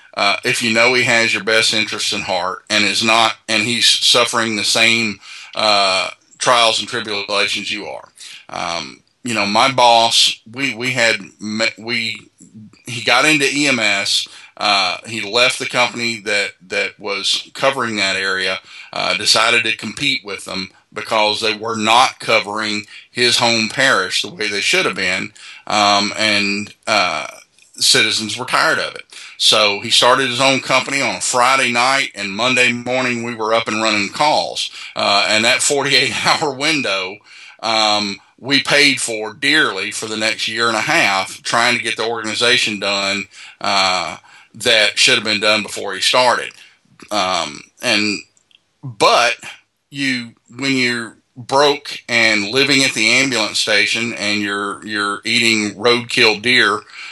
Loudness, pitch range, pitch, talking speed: -15 LUFS, 105-125 Hz, 115 Hz, 155 wpm